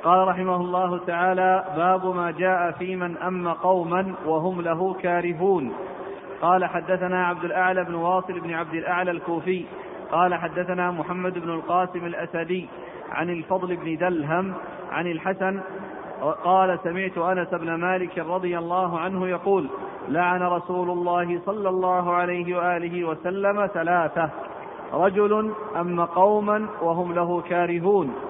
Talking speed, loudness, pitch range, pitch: 125 wpm, -24 LUFS, 175-185 Hz, 180 Hz